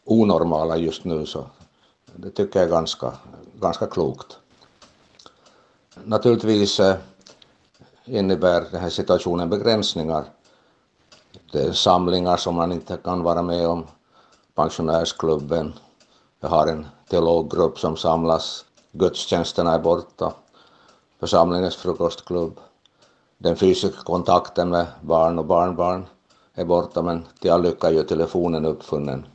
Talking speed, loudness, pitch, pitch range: 110 wpm, -21 LUFS, 85 Hz, 80-90 Hz